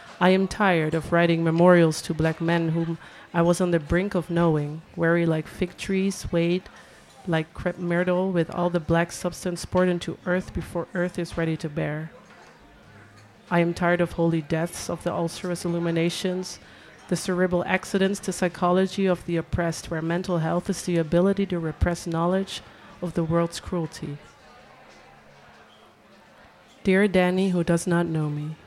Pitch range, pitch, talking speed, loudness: 165-180 Hz, 170 Hz, 160 wpm, -24 LUFS